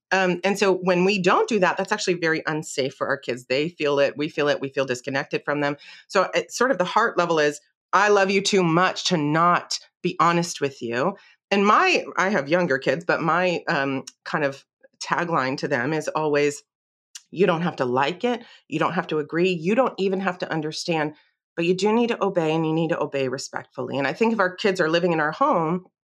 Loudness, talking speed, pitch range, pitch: -22 LUFS, 230 wpm, 145-190 Hz, 170 Hz